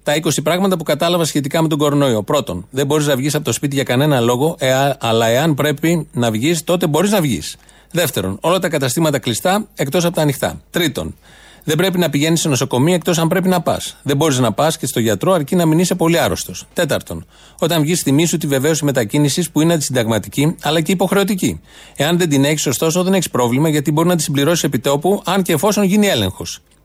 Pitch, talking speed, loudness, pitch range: 155 Hz, 215 wpm, -16 LUFS, 135-170 Hz